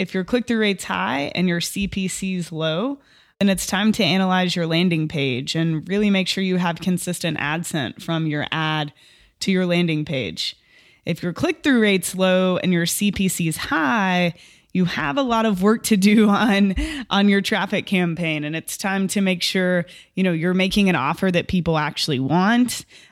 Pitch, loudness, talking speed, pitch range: 185 Hz, -20 LUFS, 185 wpm, 165-200 Hz